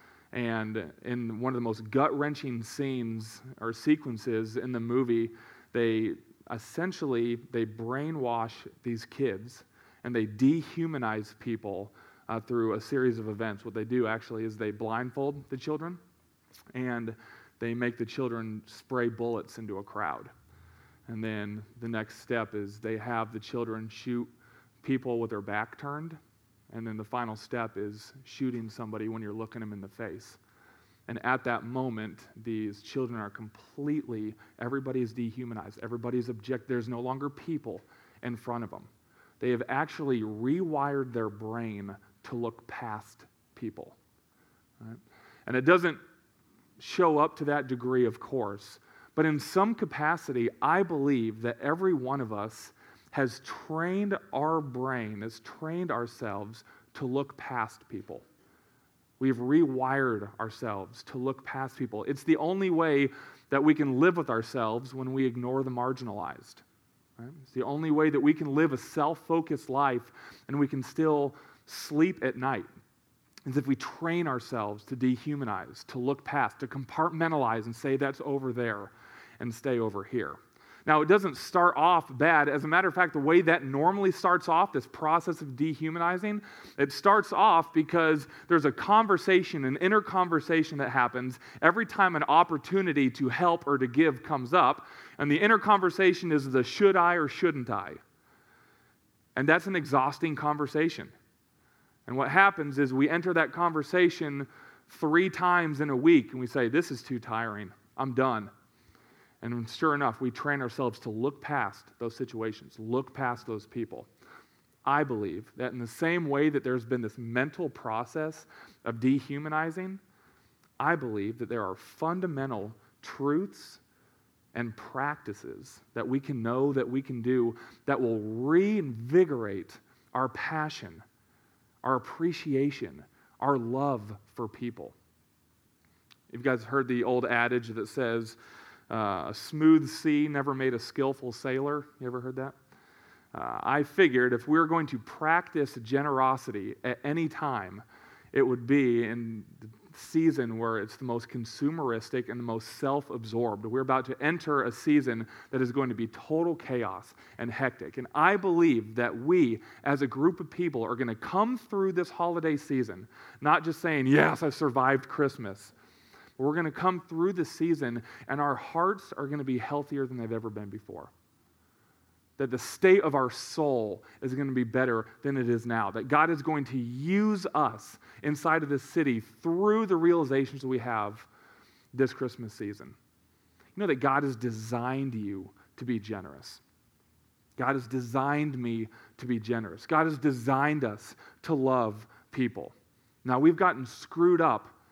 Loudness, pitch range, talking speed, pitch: -29 LUFS, 115-150 Hz, 160 wpm, 130 Hz